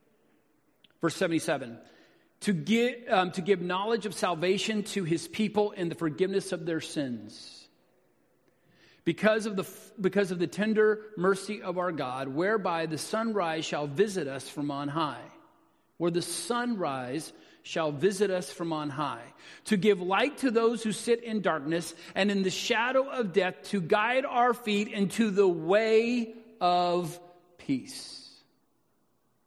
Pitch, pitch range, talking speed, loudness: 195 Hz, 170-220 Hz, 145 wpm, -29 LUFS